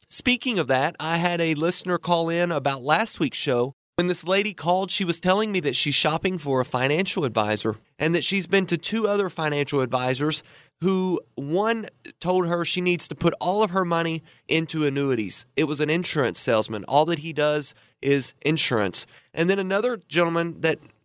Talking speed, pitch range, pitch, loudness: 190 wpm, 140-180 Hz, 165 Hz, -24 LUFS